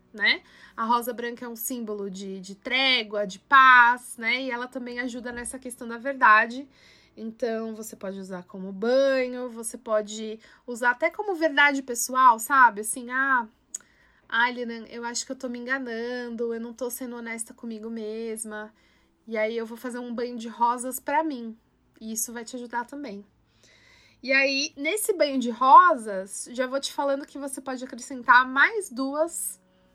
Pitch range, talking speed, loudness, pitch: 225-265 Hz, 170 wpm, -24 LUFS, 245 Hz